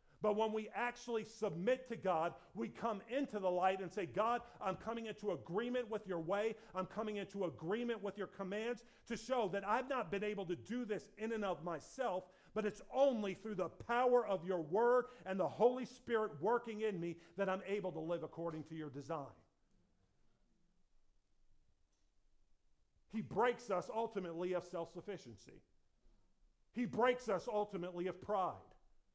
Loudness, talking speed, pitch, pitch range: -40 LUFS, 165 wpm, 205 Hz, 180-230 Hz